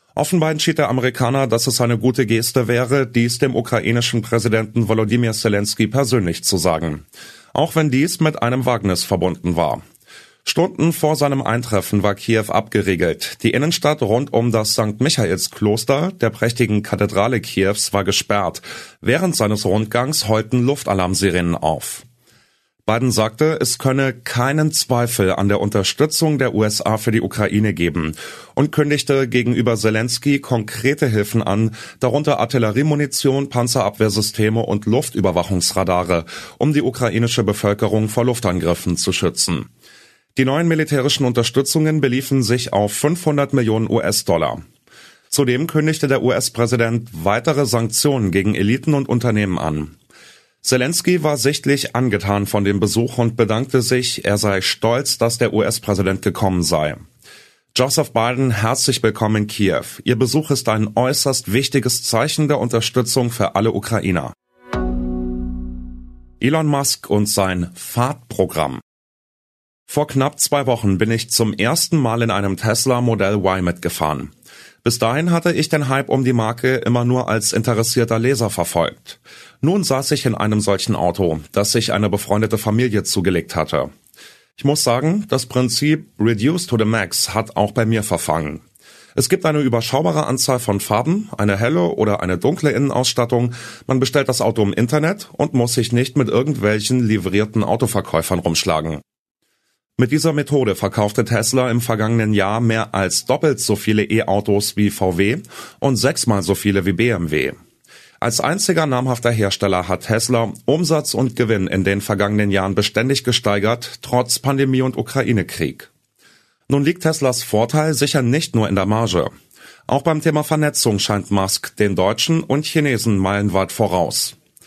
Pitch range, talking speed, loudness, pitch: 105-135 Hz, 145 wpm, -18 LUFS, 115 Hz